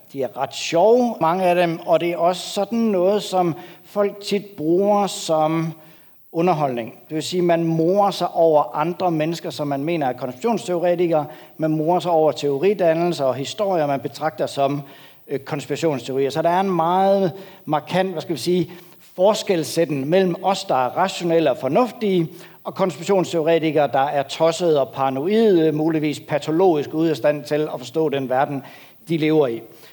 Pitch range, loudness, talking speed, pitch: 150-180 Hz, -20 LUFS, 165 wpm, 165 Hz